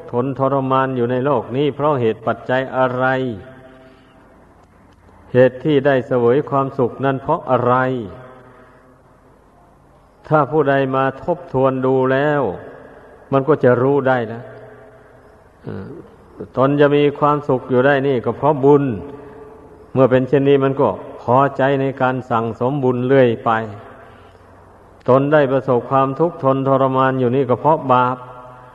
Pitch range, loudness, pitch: 125-140 Hz, -17 LUFS, 130 Hz